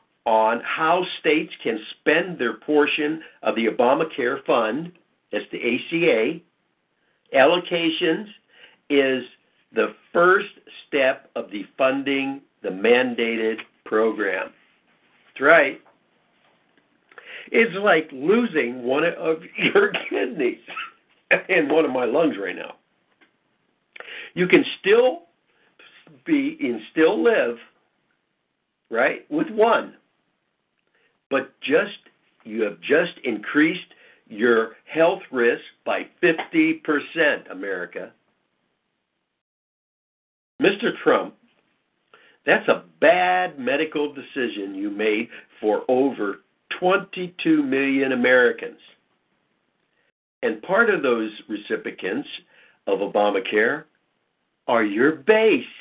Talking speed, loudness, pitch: 95 wpm, -21 LUFS, 160 Hz